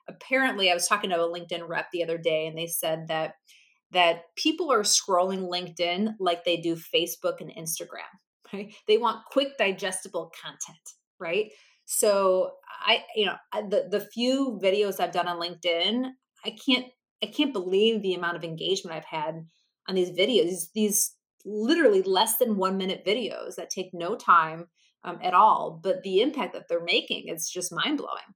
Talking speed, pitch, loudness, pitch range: 180 wpm, 190 Hz, -26 LUFS, 170-220 Hz